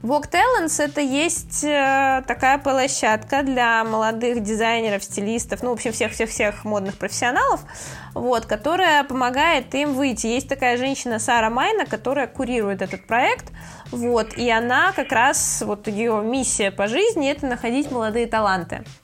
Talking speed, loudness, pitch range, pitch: 140 wpm, -20 LUFS, 220-275 Hz, 240 Hz